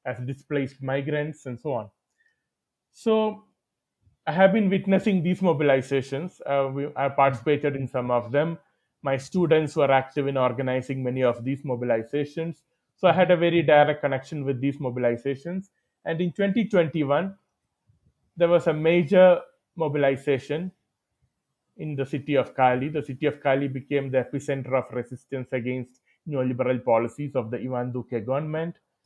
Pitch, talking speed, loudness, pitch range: 140 Hz, 145 wpm, -25 LUFS, 130-165 Hz